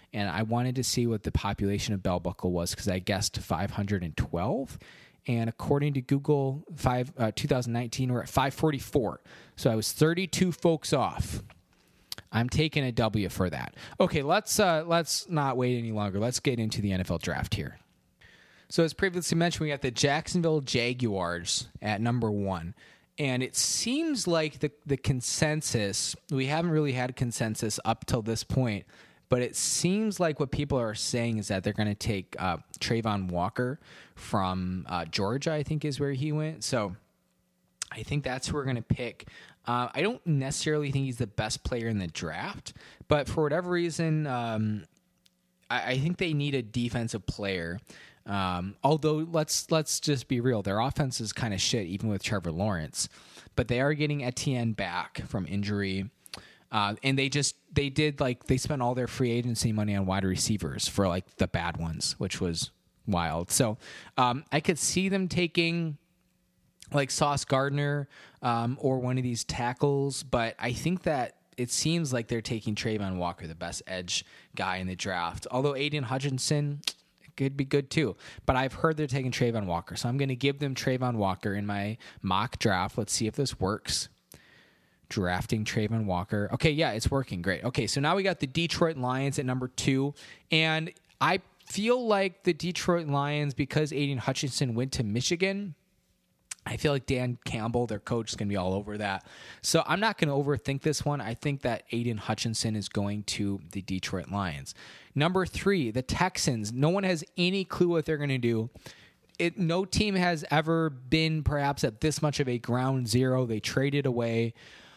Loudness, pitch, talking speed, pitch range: -29 LUFS, 125 Hz, 185 wpm, 105-150 Hz